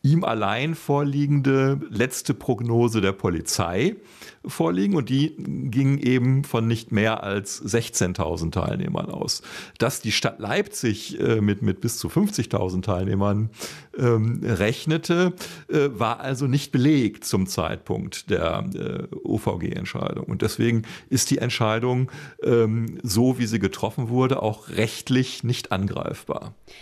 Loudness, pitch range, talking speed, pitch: -24 LUFS, 105-135 Hz, 125 wpm, 120 Hz